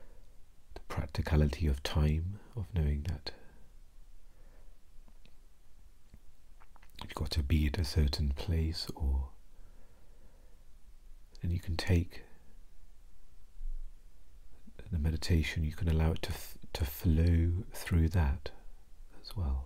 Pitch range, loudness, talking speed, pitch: 75-85 Hz, -34 LUFS, 100 wpm, 80 Hz